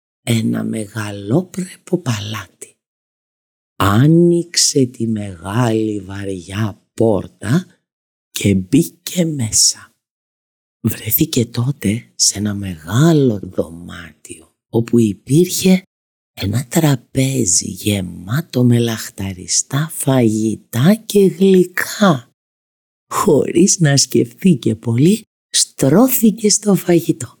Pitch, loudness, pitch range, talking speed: 120 Hz, -15 LUFS, 105-165 Hz, 75 wpm